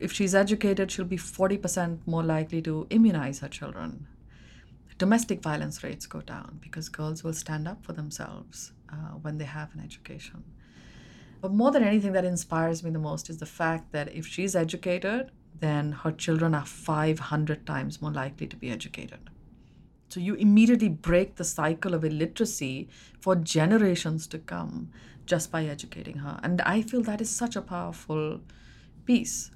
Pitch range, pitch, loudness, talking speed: 155-190 Hz, 165 Hz, -28 LUFS, 165 wpm